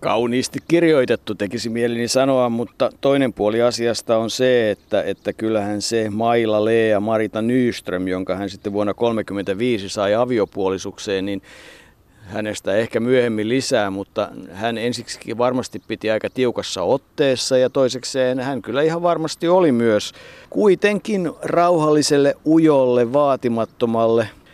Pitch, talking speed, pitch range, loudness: 115 Hz, 125 wpm, 105-130 Hz, -19 LUFS